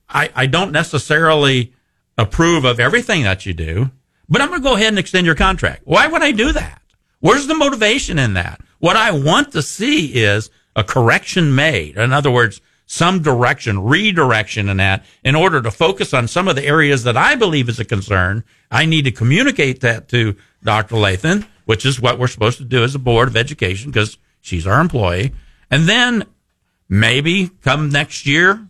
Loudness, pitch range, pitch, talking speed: -15 LUFS, 110-165 Hz, 135 Hz, 190 wpm